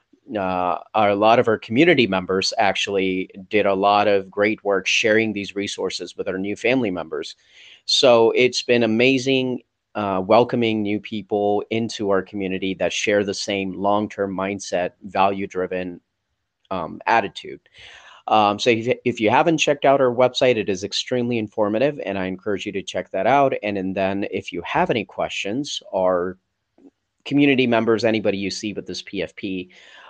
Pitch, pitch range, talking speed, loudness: 105 Hz, 95-115 Hz, 165 wpm, -20 LUFS